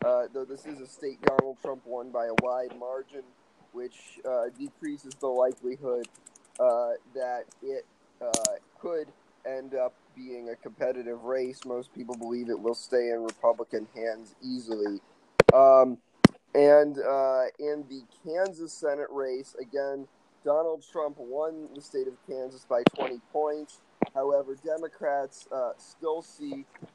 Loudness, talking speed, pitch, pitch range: -28 LUFS, 140 wpm, 135 Hz, 125-155 Hz